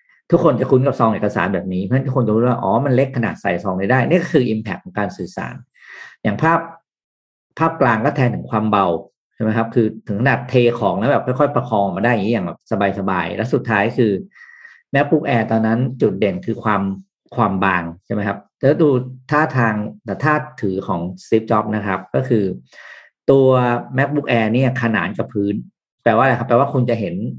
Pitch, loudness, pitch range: 115 Hz, -18 LUFS, 100-130 Hz